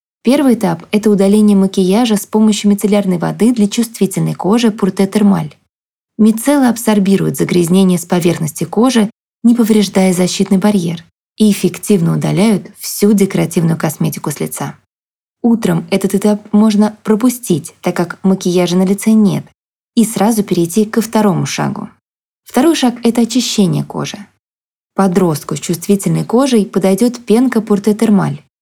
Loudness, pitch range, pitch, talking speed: -13 LUFS, 180-220 Hz, 200 Hz, 125 wpm